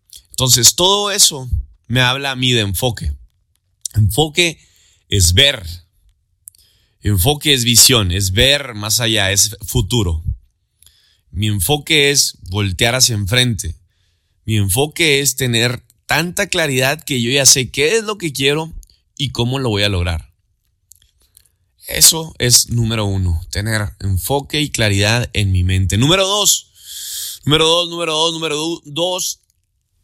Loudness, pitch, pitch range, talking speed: -14 LUFS, 110 Hz, 95-140 Hz, 140 wpm